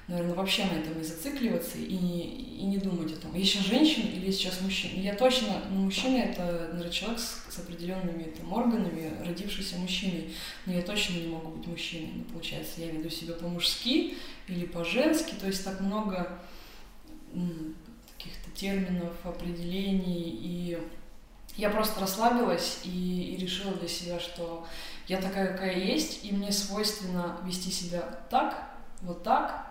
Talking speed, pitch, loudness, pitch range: 155 wpm, 185 Hz, -31 LUFS, 175-205 Hz